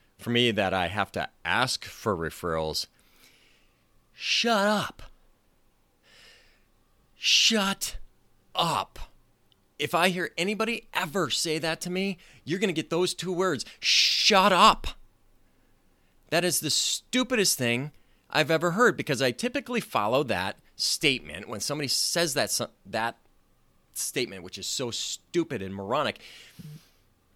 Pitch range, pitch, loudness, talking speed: 120-195 Hz, 165 Hz, -26 LUFS, 125 wpm